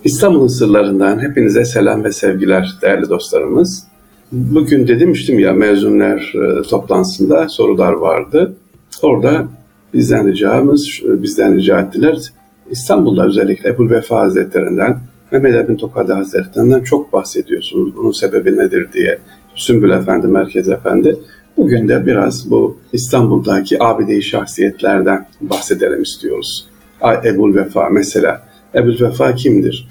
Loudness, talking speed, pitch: -13 LUFS, 110 wpm, 145 Hz